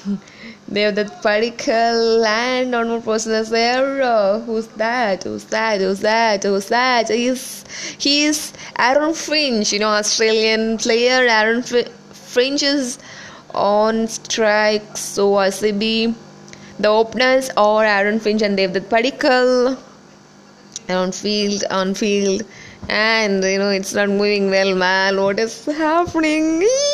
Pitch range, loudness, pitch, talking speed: 205-245 Hz, -17 LUFS, 220 Hz, 130 wpm